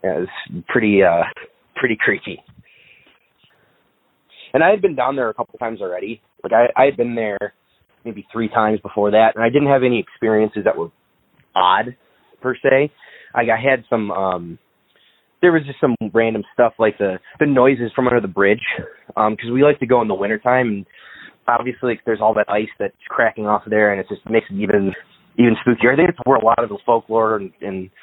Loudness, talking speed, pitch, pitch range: -18 LUFS, 210 wpm, 115 Hz, 105-125 Hz